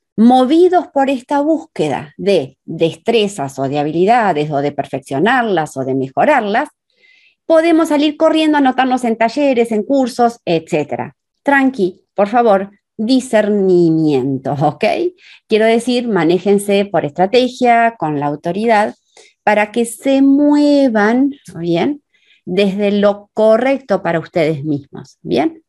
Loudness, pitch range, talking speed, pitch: -14 LUFS, 170-275 Hz, 115 wpm, 215 Hz